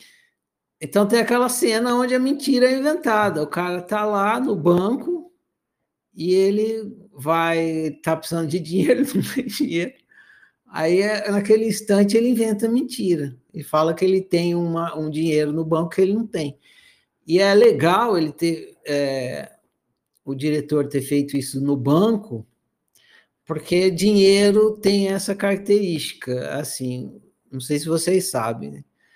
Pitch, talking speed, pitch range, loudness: 185 Hz, 150 wpm, 155-215 Hz, -20 LUFS